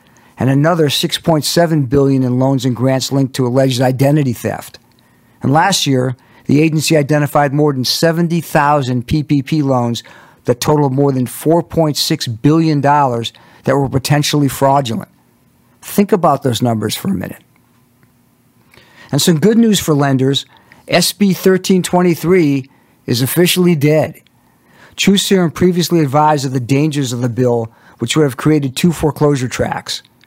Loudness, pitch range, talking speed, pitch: -14 LUFS, 130-165 Hz, 135 wpm, 145 Hz